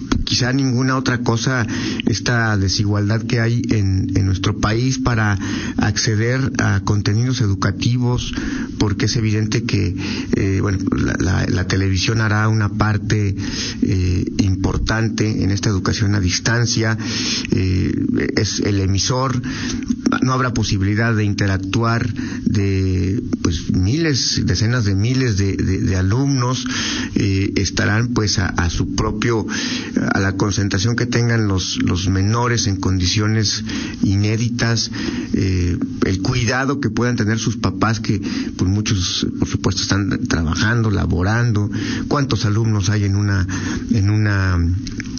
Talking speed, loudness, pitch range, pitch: 130 wpm, -18 LUFS, 95-120 Hz, 110 Hz